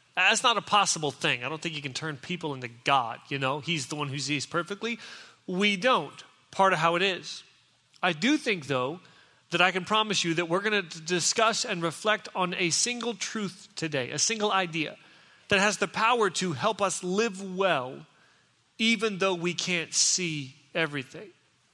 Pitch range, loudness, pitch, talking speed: 160-205 Hz, -27 LUFS, 180 Hz, 190 wpm